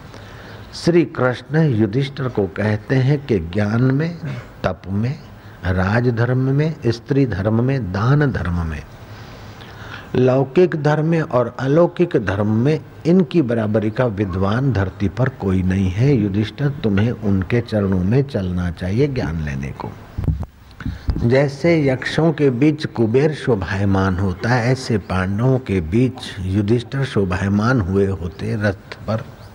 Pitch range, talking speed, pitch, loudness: 100-135 Hz, 130 wpm, 115 Hz, -19 LUFS